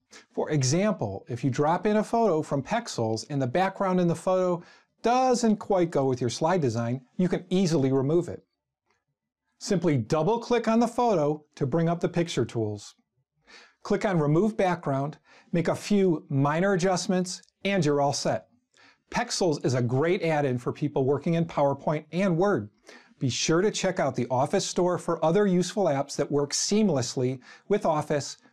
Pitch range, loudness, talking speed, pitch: 140-195 Hz, -26 LUFS, 175 wpm, 165 Hz